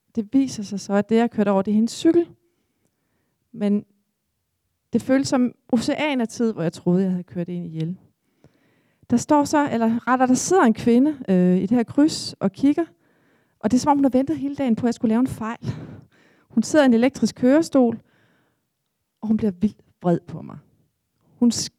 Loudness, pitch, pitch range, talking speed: -21 LUFS, 235 Hz, 210-270 Hz, 210 wpm